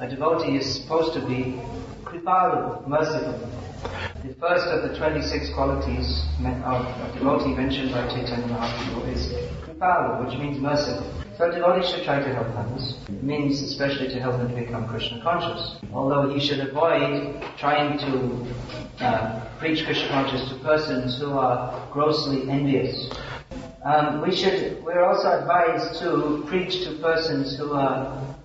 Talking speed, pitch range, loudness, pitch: 150 wpm, 125-155 Hz, -24 LUFS, 135 Hz